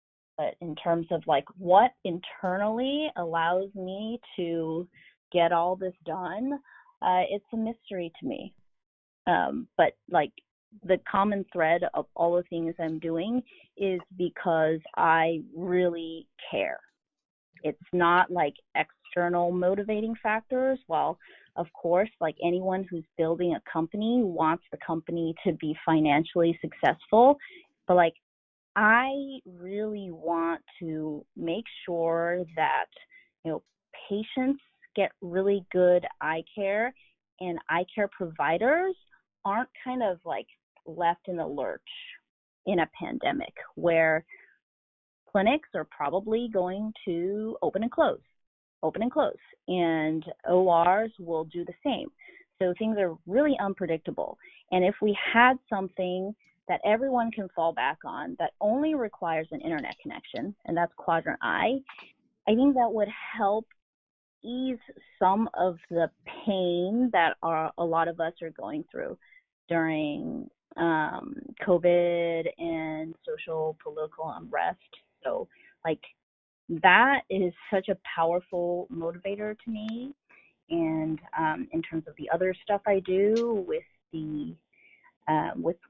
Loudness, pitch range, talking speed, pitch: -28 LUFS, 165-230 Hz, 130 wpm, 185 Hz